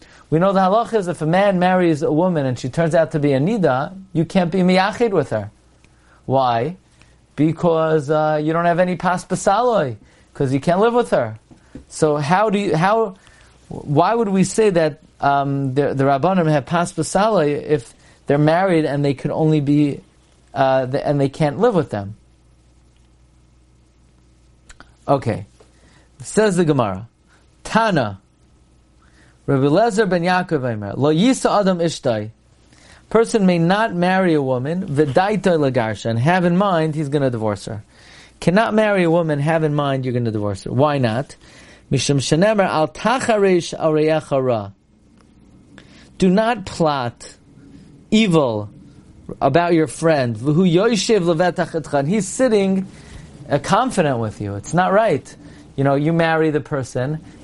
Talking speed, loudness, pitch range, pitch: 145 wpm, -18 LUFS, 130-180 Hz, 155 Hz